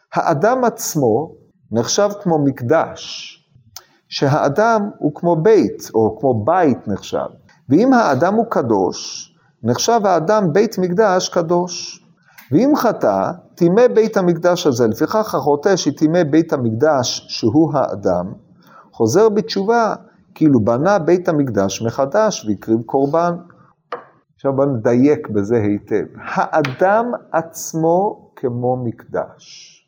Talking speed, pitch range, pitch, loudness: 105 wpm, 135-200 Hz, 165 Hz, -16 LUFS